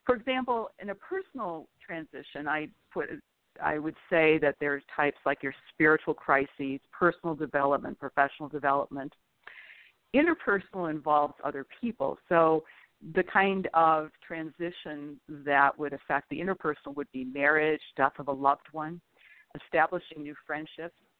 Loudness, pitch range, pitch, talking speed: -29 LUFS, 140-170 Hz, 155 Hz, 135 wpm